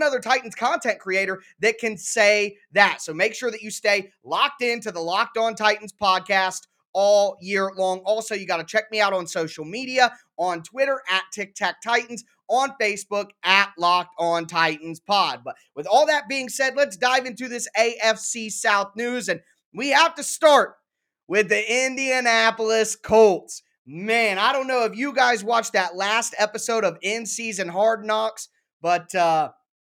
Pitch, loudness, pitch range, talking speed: 215 Hz, -22 LUFS, 190-240 Hz, 170 wpm